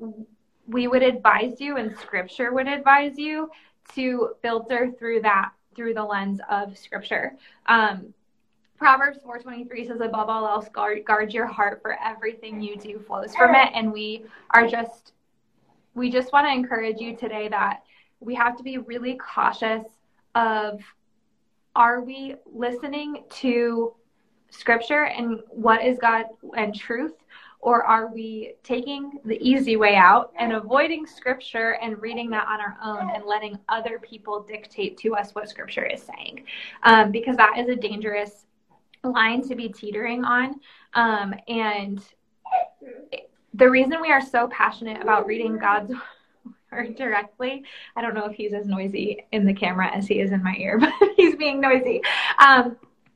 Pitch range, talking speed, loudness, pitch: 215-255 Hz, 155 wpm, -22 LUFS, 230 Hz